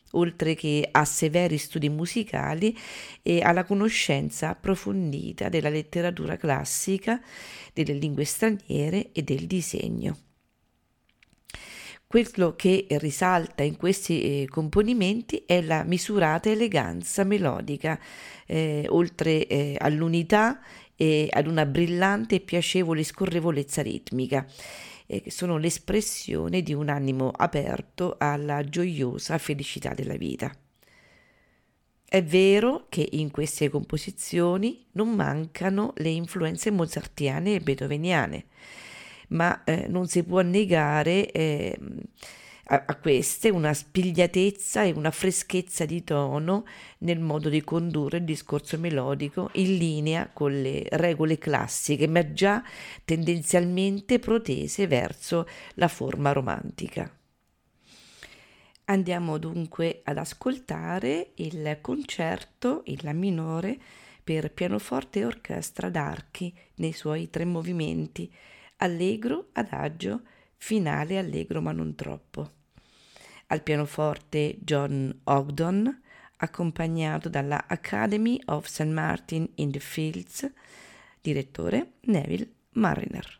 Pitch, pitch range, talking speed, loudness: 165 Hz, 150-190 Hz, 105 wpm, -27 LUFS